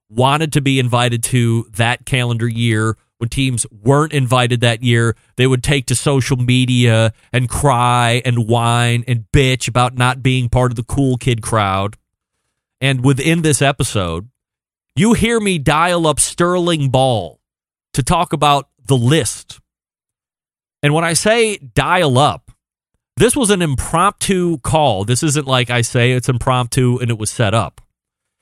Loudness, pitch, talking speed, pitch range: -15 LUFS, 125 Hz, 155 wpm, 120-145 Hz